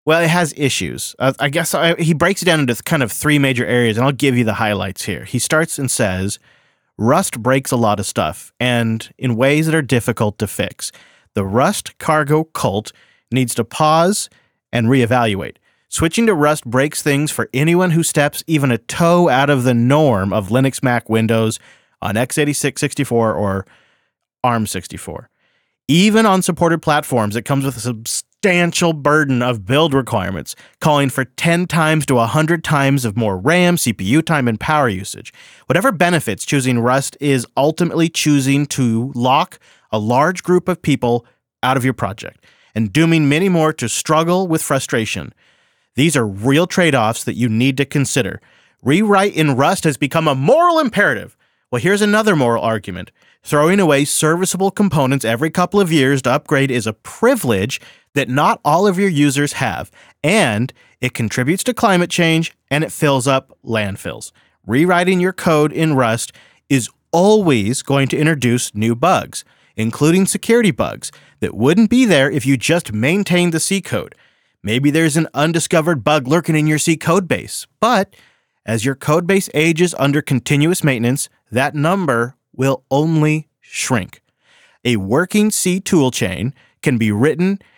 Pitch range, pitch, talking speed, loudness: 120-165 Hz, 145 Hz, 165 wpm, -16 LUFS